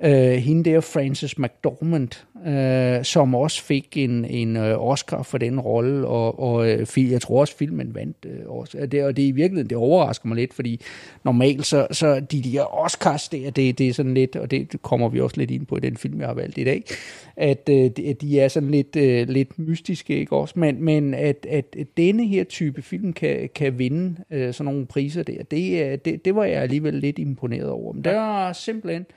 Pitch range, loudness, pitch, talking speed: 130-160 Hz, -22 LUFS, 140 Hz, 215 wpm